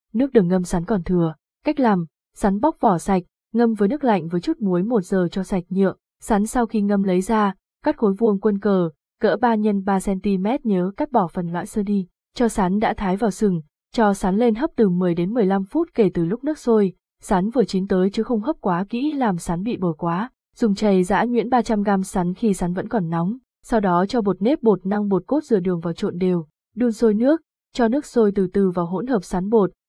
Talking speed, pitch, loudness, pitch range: 240 wpm, 205 Hz, -21 LUFS, 185-230 Hz